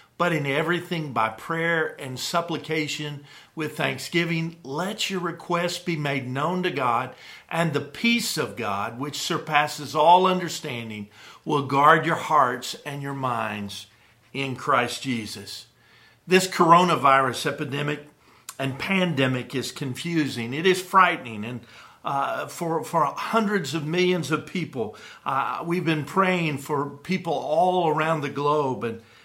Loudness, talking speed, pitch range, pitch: -24 LUFS, 135 wpm, 135-170 Hz, 150 Hz